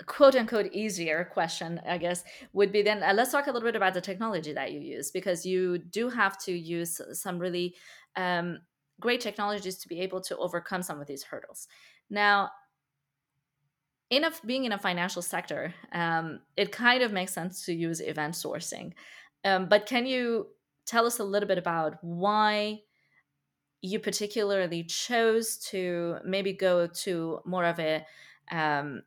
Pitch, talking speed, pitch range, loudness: 185 Hz, 165 wpm, 170-210 Hz, -29 LUFS